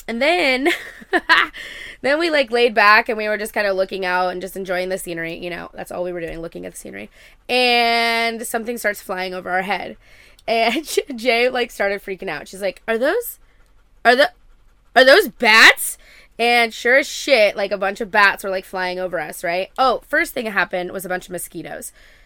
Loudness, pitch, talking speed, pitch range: -17 LUFS, 210 Hz, 210 wpm, 185-245 Hz